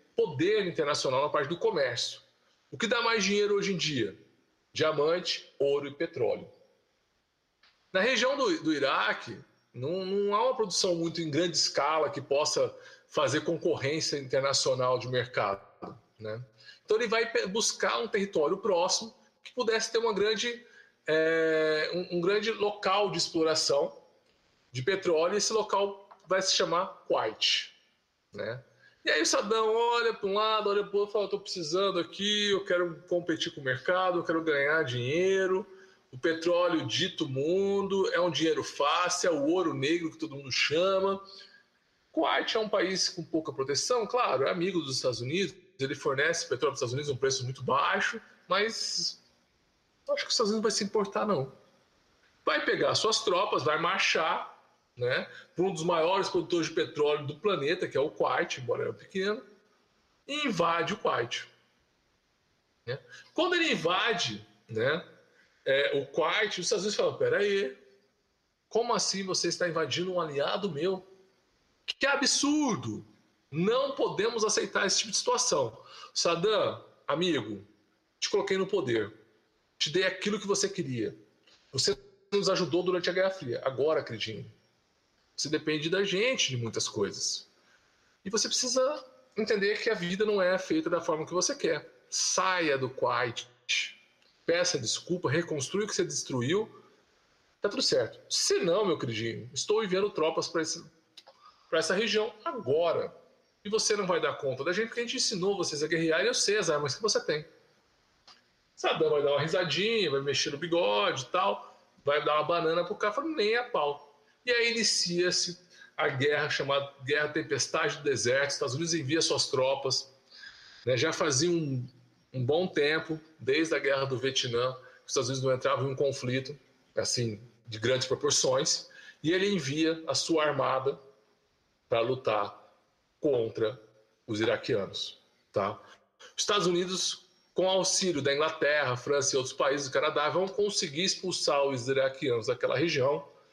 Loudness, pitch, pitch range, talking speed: -29 LUFS, 180 Hz, 150-225 Hz, 160 wpm